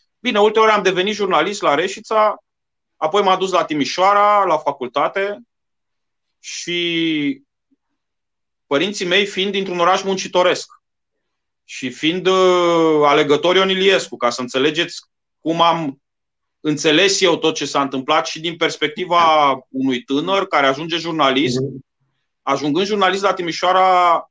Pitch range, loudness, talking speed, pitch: 150-195 Hz, -16 LUFS, 120 wpm, 170 Hz